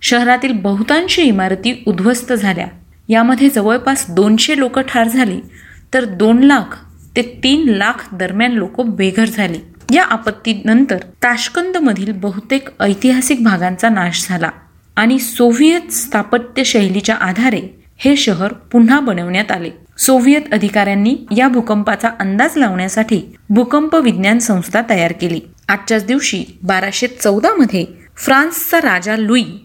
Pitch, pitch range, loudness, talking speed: 230 Hz, 205-260 Hz, -13 LUFS, 115 wpm